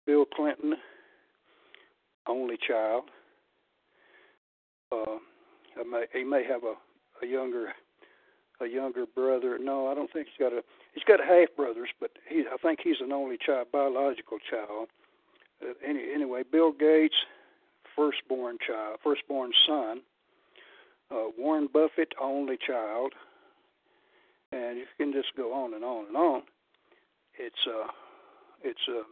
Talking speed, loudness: 135 wpm, -29 LUFS